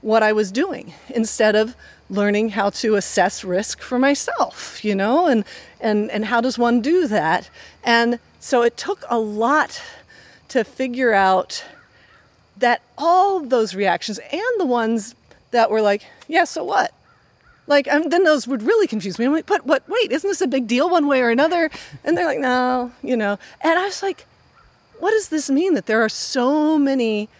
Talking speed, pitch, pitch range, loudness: 190 wpm, 250 Hz, 220-315 Hz, -19 LUFS